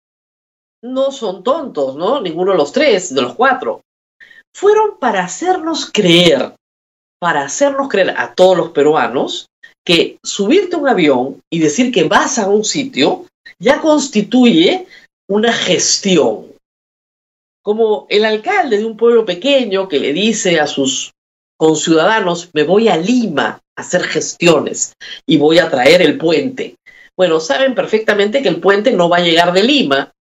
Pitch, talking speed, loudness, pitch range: 215 Hz, 150 wpm, -13 LUFS, 175-280 Hz